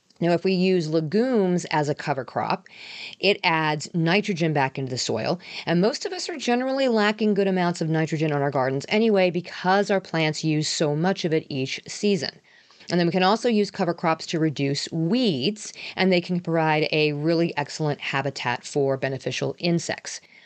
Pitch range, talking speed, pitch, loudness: 150-195 Hz, 185 wpm, 170 Hz, -23 LUFS